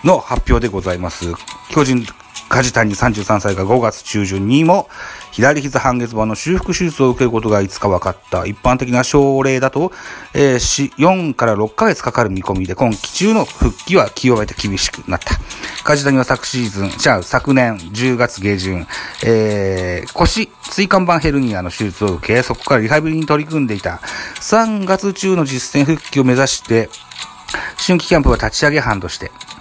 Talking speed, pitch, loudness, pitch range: 315 characters per minute, 125 Hz, -15 LUFS, 105-145 Hz